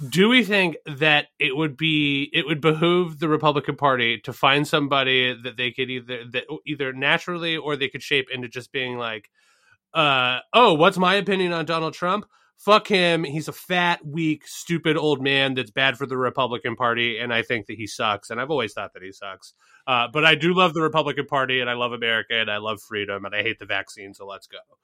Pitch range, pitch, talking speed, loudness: 125-165 Hz, 145 Hz, 220 wpm, -21 LUFS